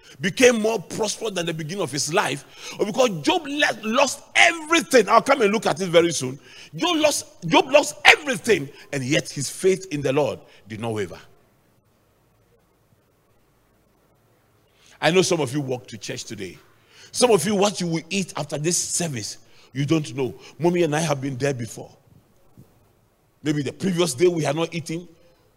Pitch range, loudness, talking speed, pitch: 130-195 Hz, -21 LUFS, 175 wpm, 160 Hz